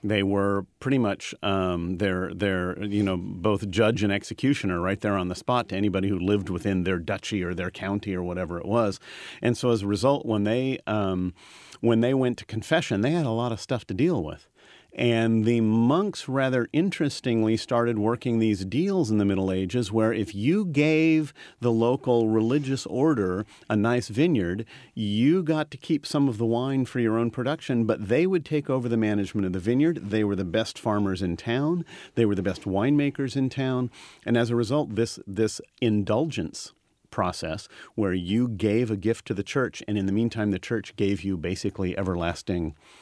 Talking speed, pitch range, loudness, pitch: 195 wpm, 100-125 Hz, -26 LUFS, 110 Hz